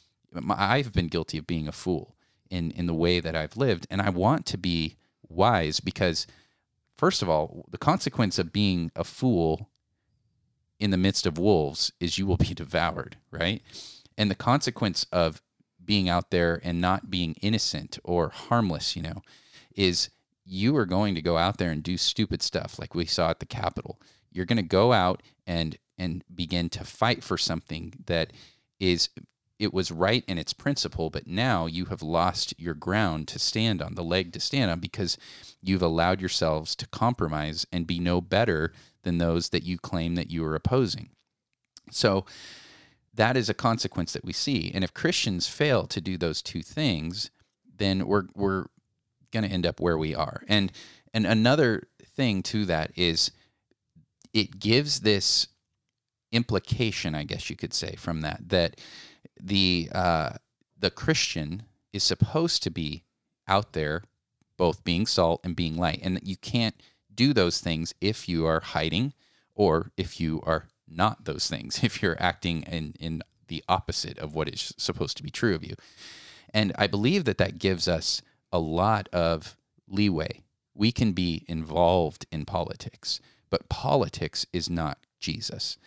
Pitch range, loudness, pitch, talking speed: 85-110 Hz, -27 LUFS, 95 Hz, 170 wpm